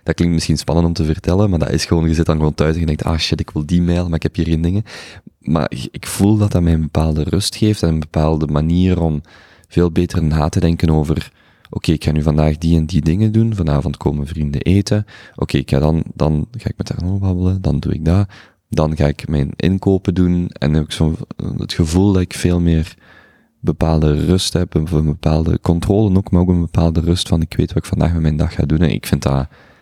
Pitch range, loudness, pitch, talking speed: 75-90 Hz, -17 LUFS, 85 Hz, 255 wpm